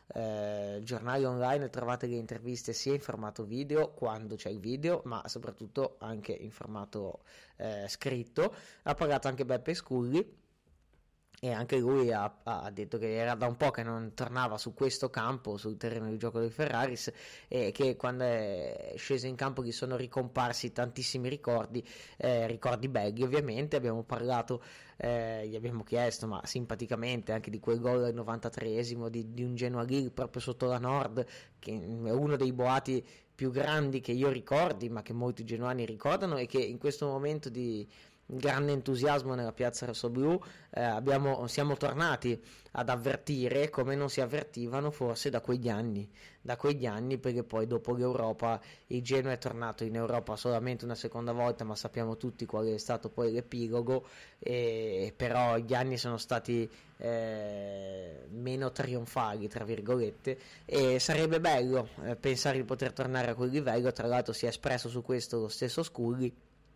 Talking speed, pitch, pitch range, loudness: 165 wpm, 125 Hz, 115-130 Hz, -34 LUFS